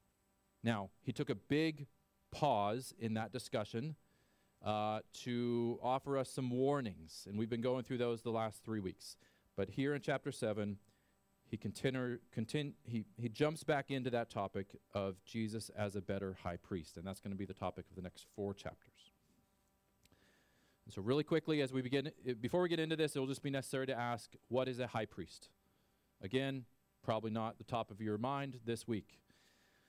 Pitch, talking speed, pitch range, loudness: 115 Hz, 185 wpm, 100-130 Hz, -41 LUFS